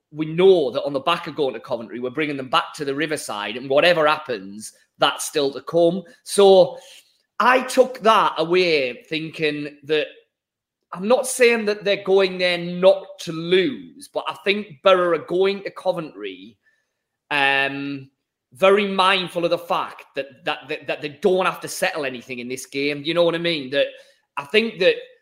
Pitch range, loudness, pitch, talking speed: 150-200 Hz, -20 LUFS, 175 Hz, 185 wpm